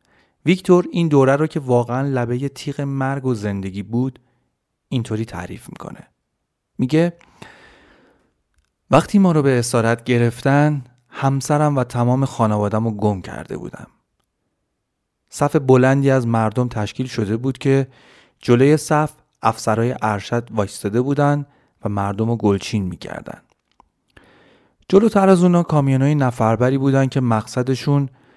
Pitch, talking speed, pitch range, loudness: 130 Hz, 120 wpm, 115-145 Hz, -18 LUFS